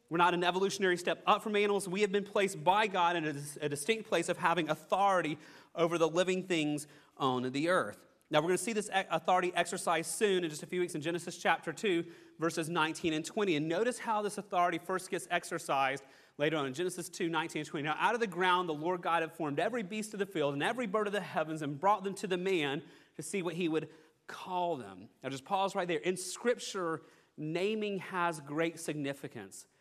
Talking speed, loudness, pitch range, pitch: 225 wpm, -33 LUFS, 155-190 Hz, 175 Hz